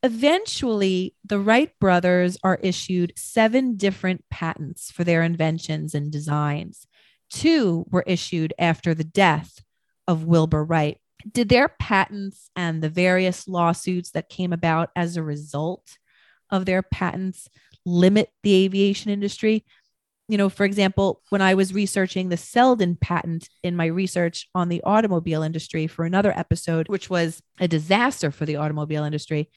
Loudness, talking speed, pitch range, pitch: -22 LUFS, 145 wpm, 160-195 Hz, 180 Hz